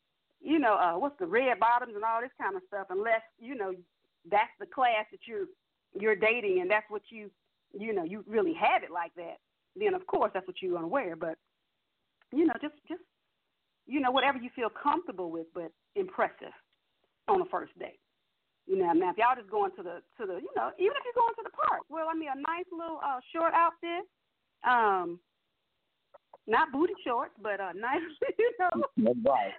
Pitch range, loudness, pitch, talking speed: 210-345 Hz, -31 LUFS, 270 Hz, 205 wpm